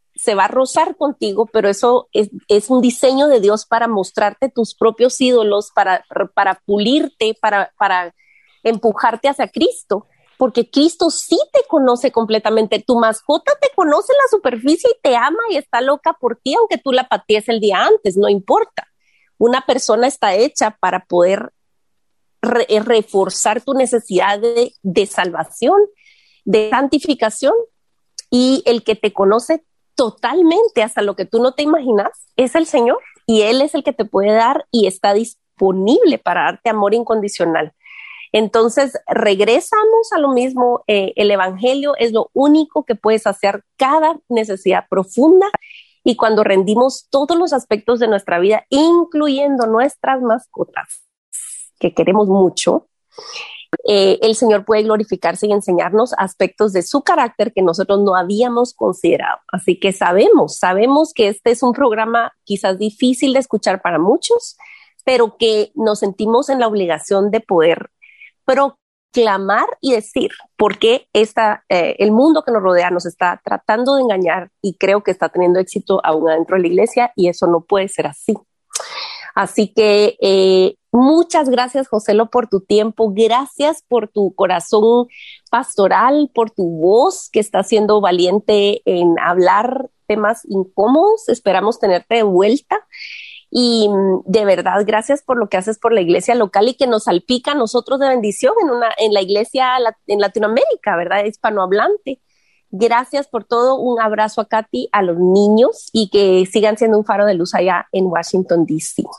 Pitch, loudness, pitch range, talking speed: 225 Hz, -15 LUFS, 200-265 Hz, 160 wpm